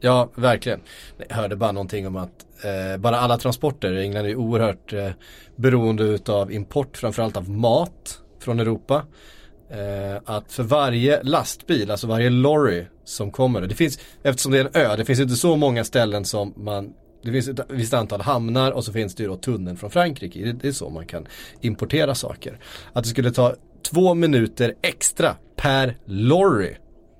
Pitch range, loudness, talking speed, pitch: 105-130 Hz, -22 LUFS, 180 wpm, 115 Hz